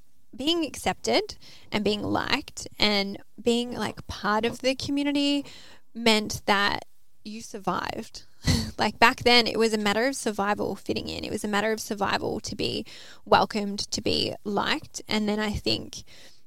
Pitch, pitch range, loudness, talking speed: 225 Hz, 210-255 Hz, -26 LUFS, 155 wpm